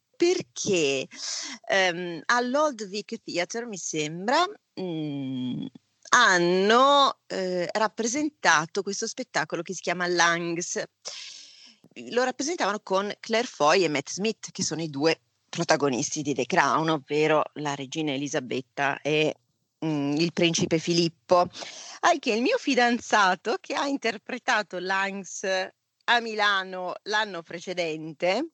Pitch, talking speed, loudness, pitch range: 180 Hz, 115 wpm, -25 LUFS, 160-230 Hz